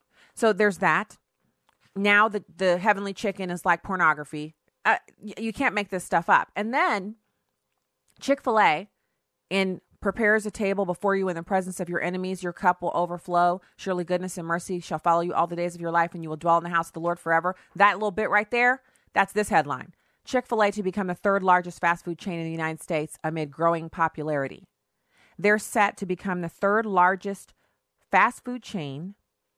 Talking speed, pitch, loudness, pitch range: 200 wpm, 185 Hz, -25 LUFS, 170-205 Hz